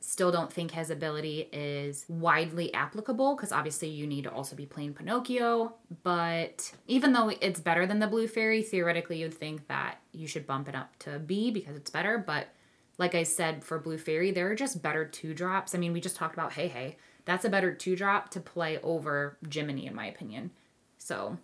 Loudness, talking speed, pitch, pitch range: -31 LUFS, 205 wpm, 165 Hz, 155-190 Hz